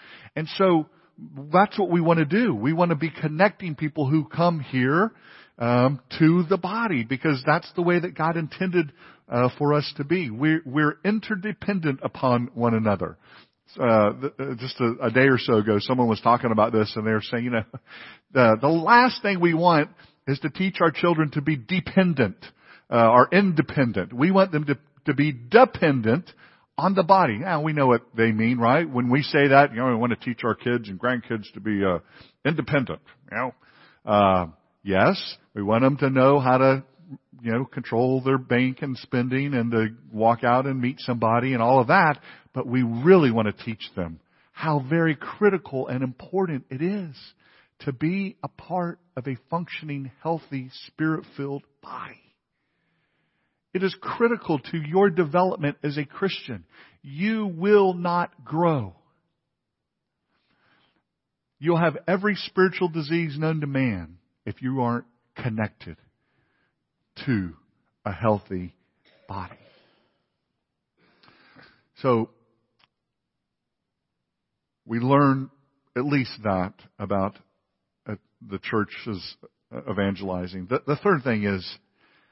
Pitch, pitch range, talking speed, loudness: 140 Hz, 120-170 Hz, 150 wpm, -23 LUFS